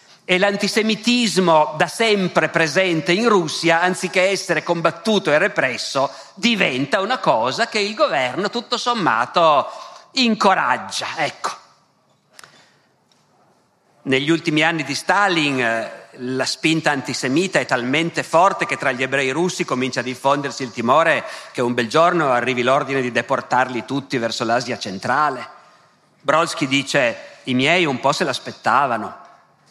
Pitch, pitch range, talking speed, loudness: 165 Hz, 135-200 Hz, 125 wpm, -18 LUFS